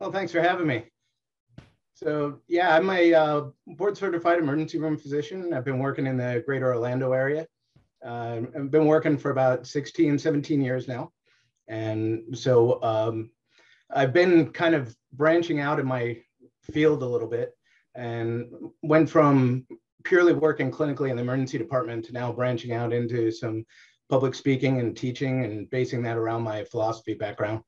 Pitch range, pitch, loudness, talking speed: 120-155 Hz, 130 Hz, -25 LUFS, 165 wpm